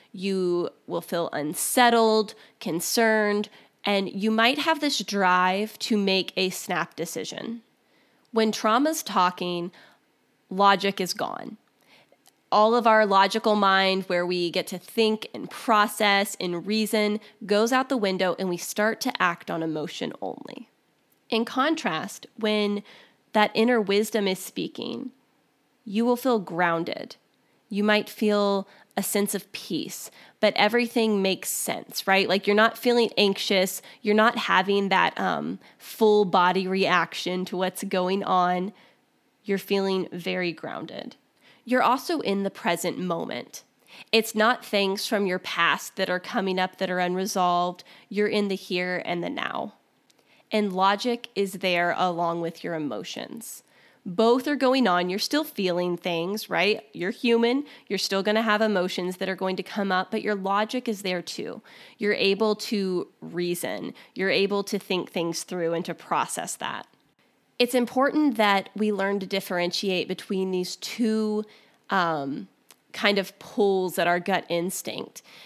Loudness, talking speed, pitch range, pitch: -25 LUFS, 150 wpm, 185-220 Hz, 200 Hz